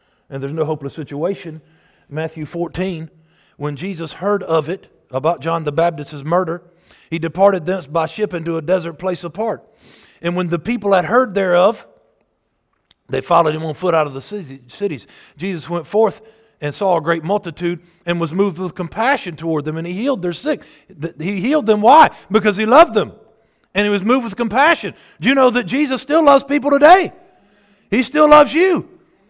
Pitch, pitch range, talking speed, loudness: 180 Hz, 165-220 Hz, 185 wpm, -17 LUFS